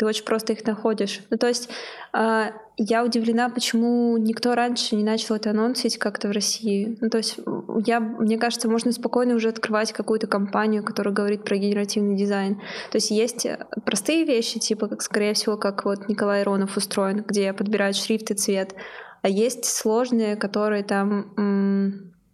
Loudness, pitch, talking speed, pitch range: -23 LUFS, 220 Hz, 170 wpm, 205-230 Hz